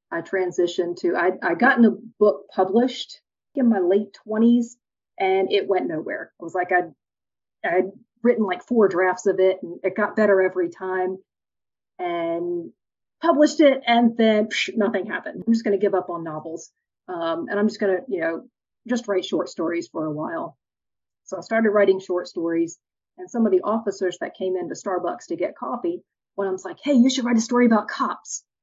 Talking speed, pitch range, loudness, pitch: 195 wpm, 185-240 Hz, -22 LUFS, 200 Hz